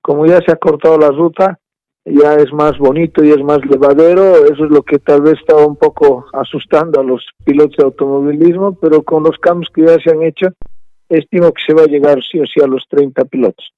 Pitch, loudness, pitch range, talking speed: 160 Hz, -10 LUFS, 145-175 Hz, 225 wpm